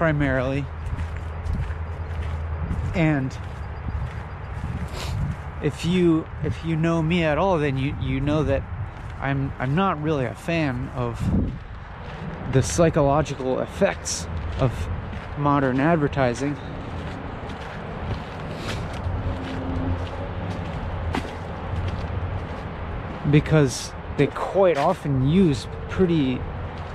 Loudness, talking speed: -25 LUFS, 75 wpm